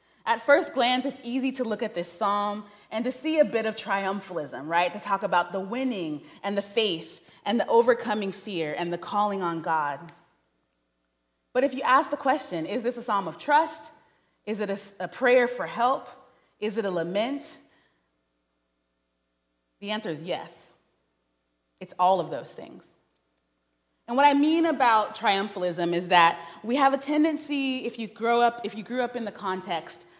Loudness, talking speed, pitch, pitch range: -26 LUFS, 175 wpm, 205 Hz, 170-250 Hz